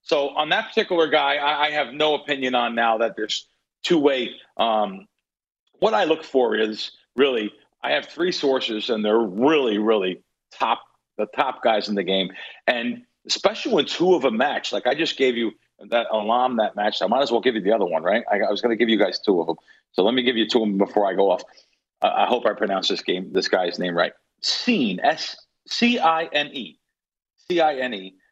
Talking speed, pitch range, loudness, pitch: 230 wpm, 110-155 Hz, -22 LUFS, 130 Hz